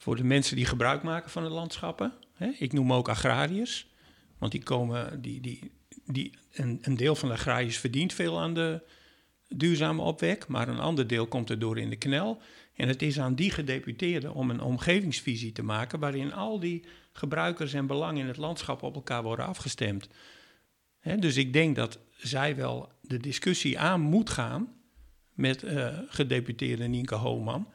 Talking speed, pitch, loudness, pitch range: 170 wpm, 140 Hz, -30 LUFS, 125-165 Hz